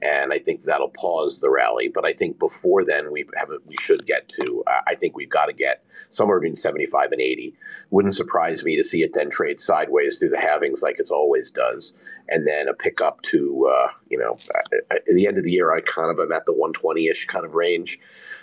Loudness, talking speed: -21 LUFS, 230 wpm